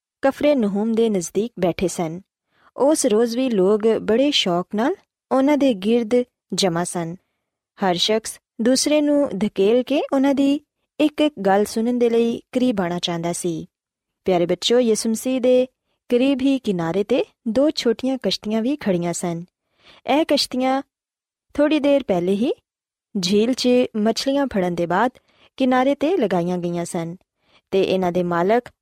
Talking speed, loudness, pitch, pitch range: 150 wpm, -20 LUFS, 225 Hz, 185-265 Hz